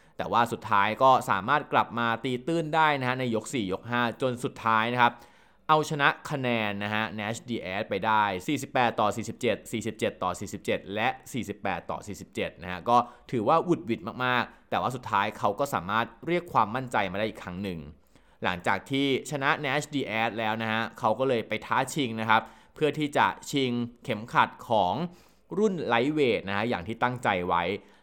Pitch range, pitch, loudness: 110-140 Hz, 120 Hz, -27 LUFS